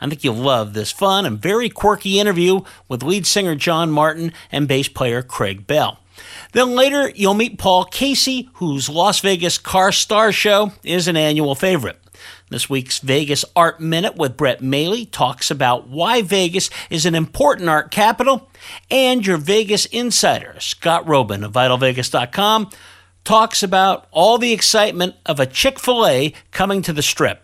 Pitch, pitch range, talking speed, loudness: 180 Hz, 145-210 Hz, 165 wpm, -16 LUFS